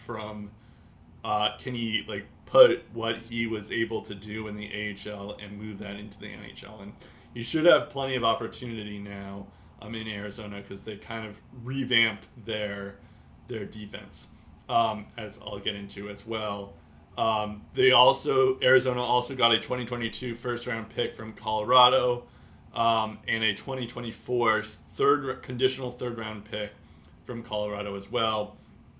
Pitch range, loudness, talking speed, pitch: 105-120 Hz, -27 LUFS, 150 wpm, 110 Hz